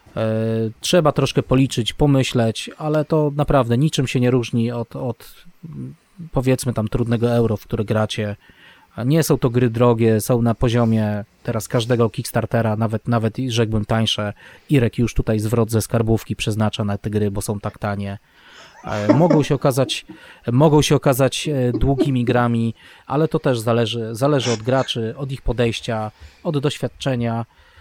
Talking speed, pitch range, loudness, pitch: 150 wpm, 110-135 Hz, -19 LUFS, 120 Hz